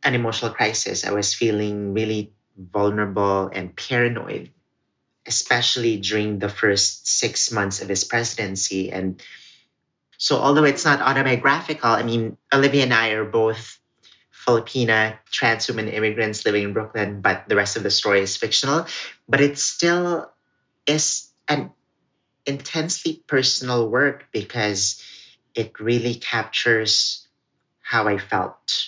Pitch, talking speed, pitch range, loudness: 115 Hz, 130 wpm, 105-125 Hz, -21 LUFS